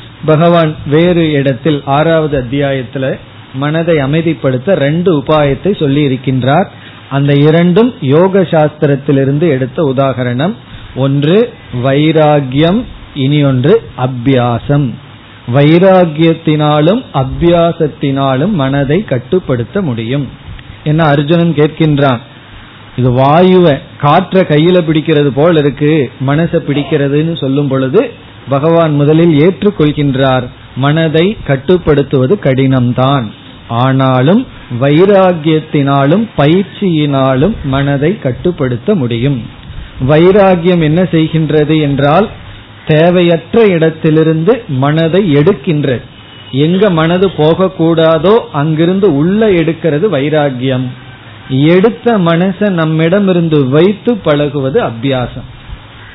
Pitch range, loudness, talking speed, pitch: 135-165 Hz, -10 LUFS, 80 wpm, 150 Hz